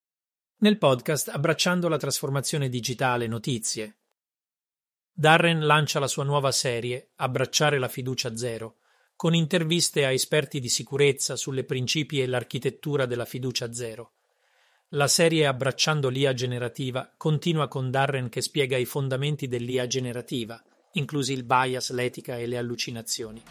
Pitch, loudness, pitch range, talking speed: 135 Hz, -25 LUFS, 125-150 Hz, 130 wpm